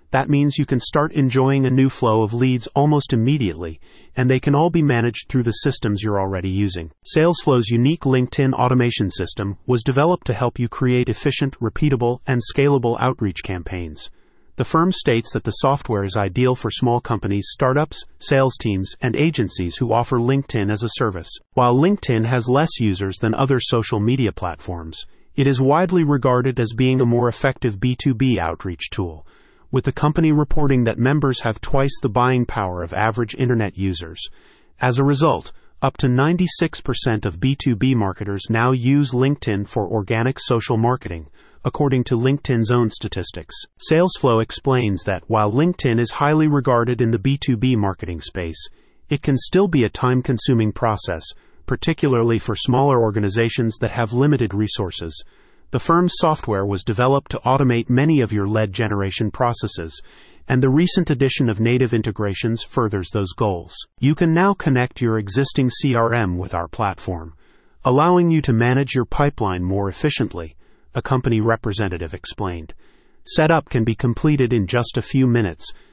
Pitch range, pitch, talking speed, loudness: 105-135 Hz, 120 Hz, 160 wpm, -19 LUFS